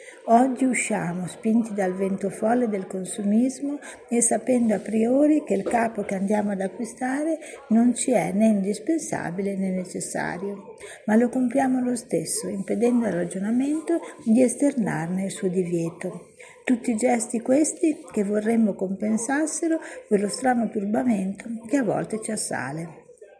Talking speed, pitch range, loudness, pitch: 140 wpm, 200-255 Hz, -24 LUFS, 225 Hz